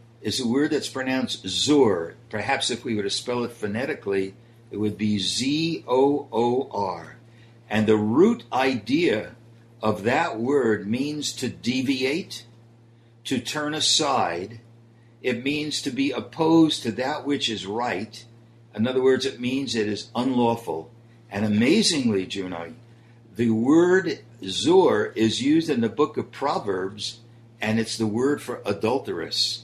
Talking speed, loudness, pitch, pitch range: 140 wpm, -24 LUFS, 115 Hz, 110-130 Hz